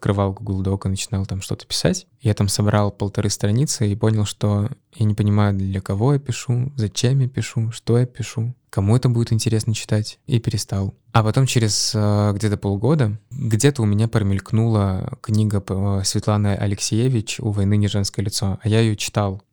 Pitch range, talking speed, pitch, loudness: 100-115 Hz, 175 wpm, 105 Hz, -20 LUFS